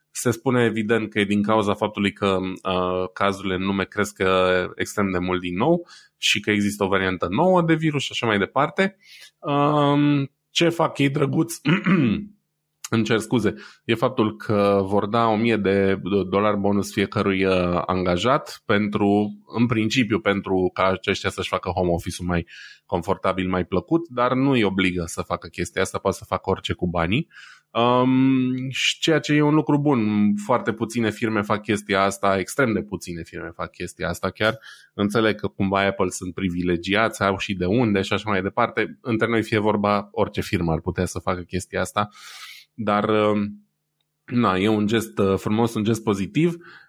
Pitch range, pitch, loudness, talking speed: 95-115 Hz, 105 Hz, -22 LUFS, 175 wpm